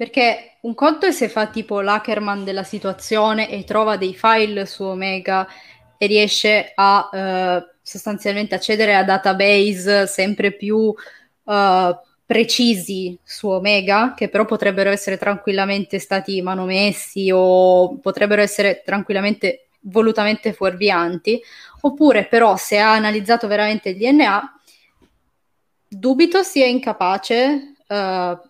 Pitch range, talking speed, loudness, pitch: 195-220 Hz, 115 wpm, -17 LUFS, 205 Hz